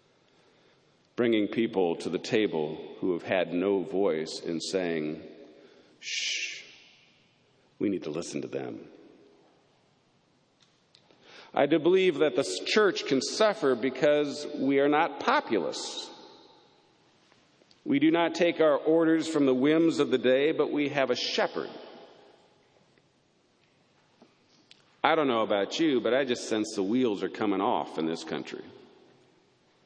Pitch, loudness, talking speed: 145 Hz, -27 LUFS, 135 wpm